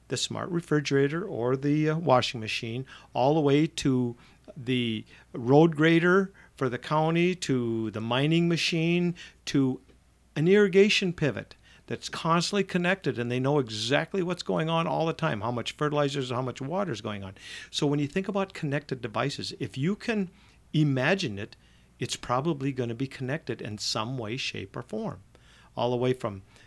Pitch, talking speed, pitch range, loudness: 140 Hz, 170 wpm, 120-165 Hz, -27 LUFS